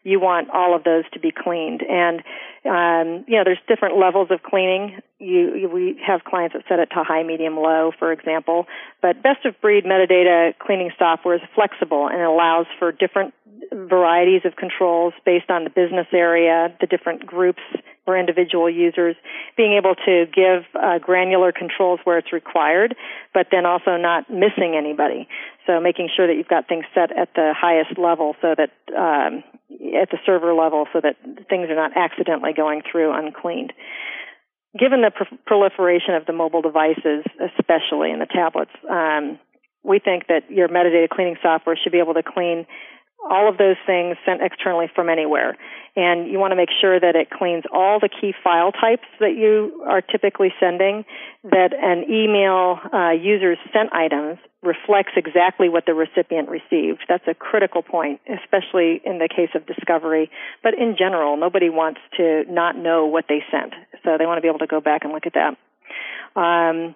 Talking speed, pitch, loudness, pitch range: 180 wpm, 175 Hz, -19 LUFS, 165-190 Hz